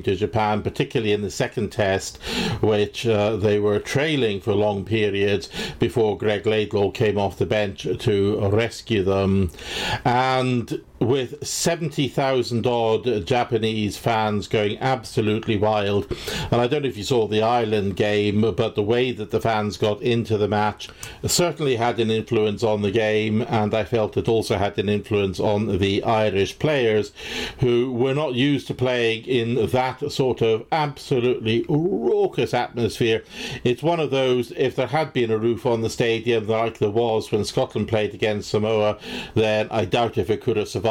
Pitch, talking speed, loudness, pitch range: 110 Hz, 170 wpm, -22 LUFS, 105-120 Hz